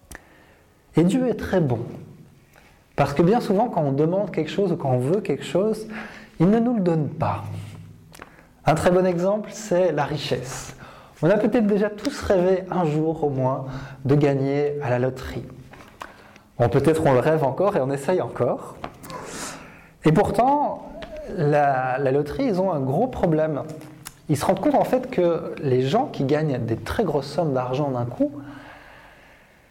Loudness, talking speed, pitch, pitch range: -22 LUFS, 175 wpm, 155 Hz, 140-190 Hz